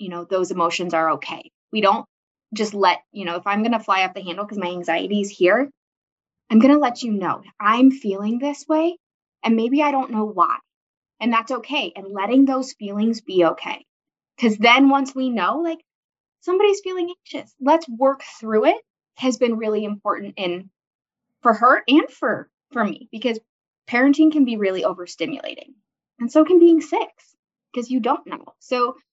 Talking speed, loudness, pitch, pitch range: 185 wpm, -20 LUFS, 240 Hz, 205-285 Hz